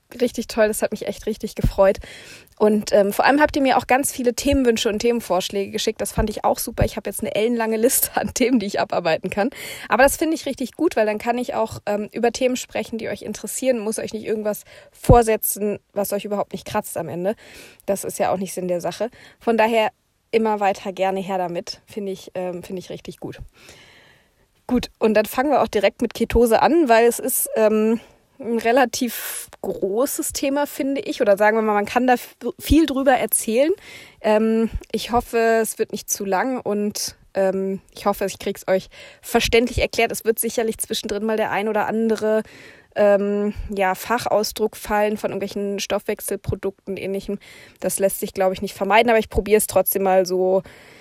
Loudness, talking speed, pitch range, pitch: -21 LUFS, 200 wpm, 200-235 Hz, 215 Hz